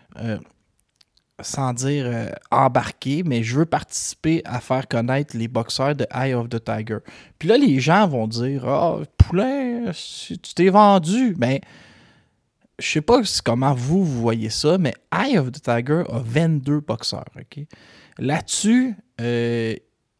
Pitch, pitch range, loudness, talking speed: 135 Hz, 115-165 Hz, -21 LUFS, 165 wpm